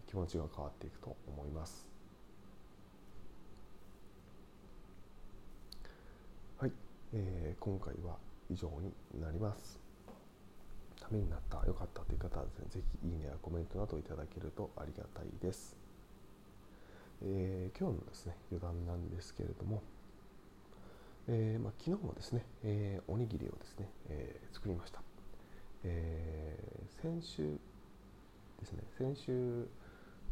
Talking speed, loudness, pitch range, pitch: 250 characters per minute, -44 LUFS, 85-105 Hz, 95 Hz